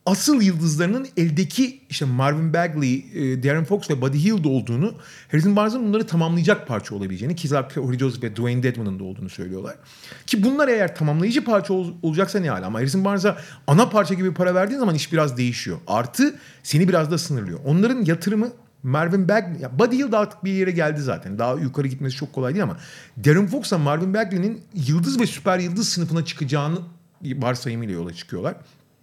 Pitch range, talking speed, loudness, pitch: 135-195 Hz, 175 wpm, -22 LUFS, 165 Hz